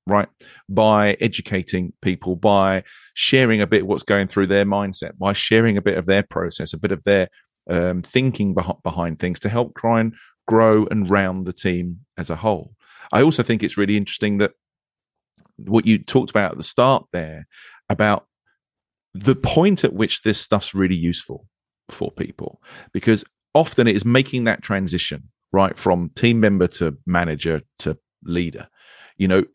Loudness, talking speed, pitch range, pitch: -20 LUFS, 170 wpm, 90-110 Hz, 100 Hz